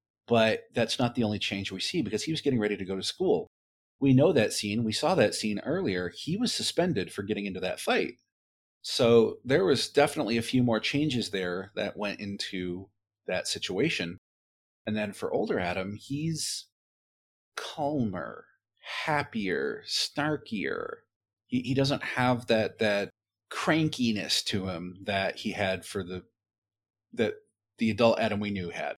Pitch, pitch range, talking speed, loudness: 105 Hz, 95-120 Hz, 160 wpm, -29 LUFS